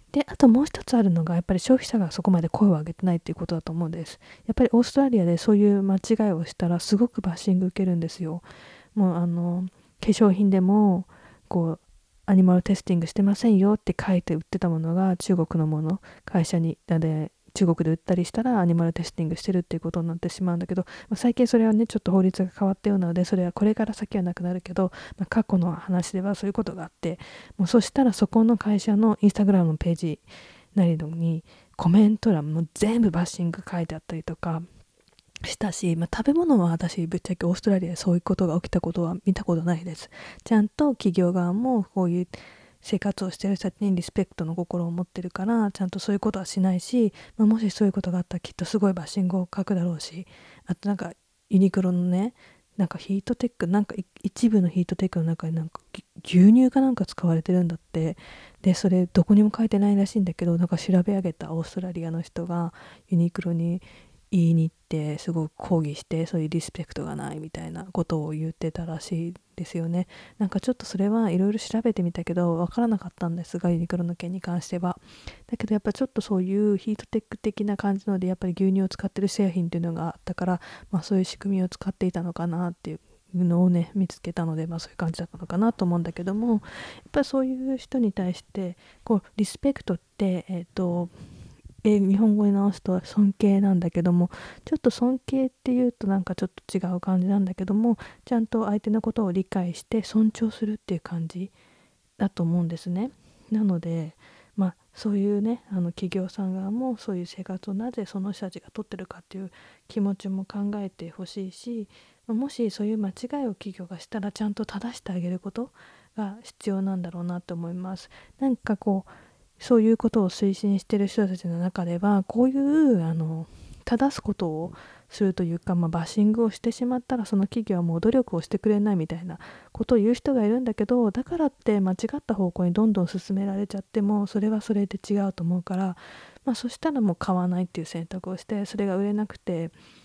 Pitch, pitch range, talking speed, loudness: 190 Hz, 175-210 Hz, 440 characters per minute, -25 LUFS